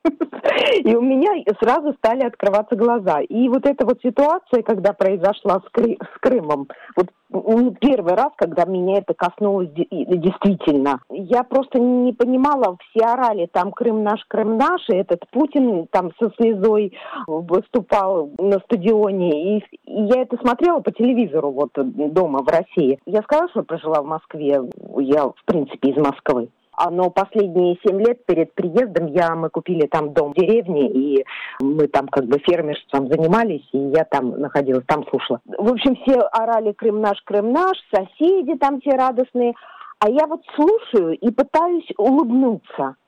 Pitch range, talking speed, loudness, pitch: 165-250 Hz, 155 wpm, -19 LUFS, 210 Hz